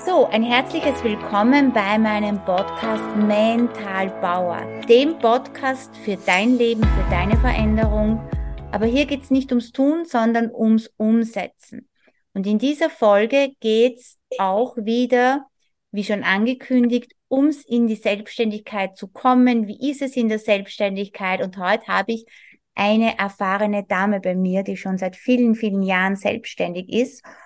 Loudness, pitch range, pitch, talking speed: -20 LUFS, 195-250 Hz, 220 Hz, 145 wpm